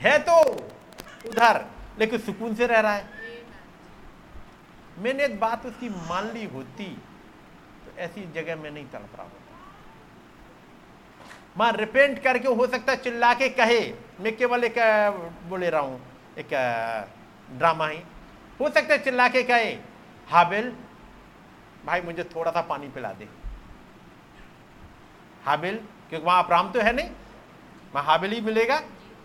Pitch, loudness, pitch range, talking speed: 220 Hz, -24 LUFS, 175-240 Hz, 130 wpm